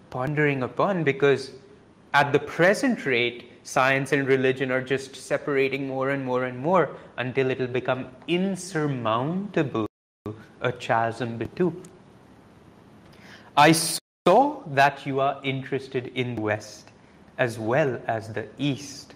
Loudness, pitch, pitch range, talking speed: -24 LUFS, 135 Hz, 125-145 Hz, 130 wpm